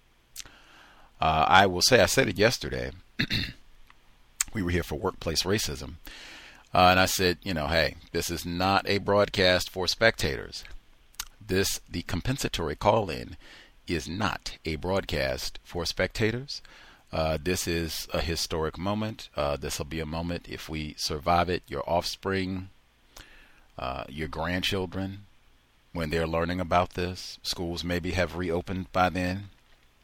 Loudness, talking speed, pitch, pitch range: -27 LUFS, 140 wpm, 85 Hz, 80-95 Hz